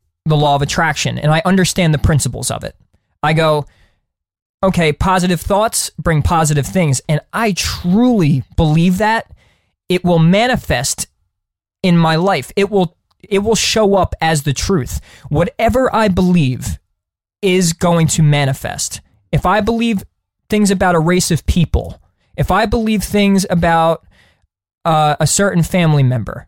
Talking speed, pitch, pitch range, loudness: 145 wpm, 165 Hz, 140-190 Hz, -14 LUFS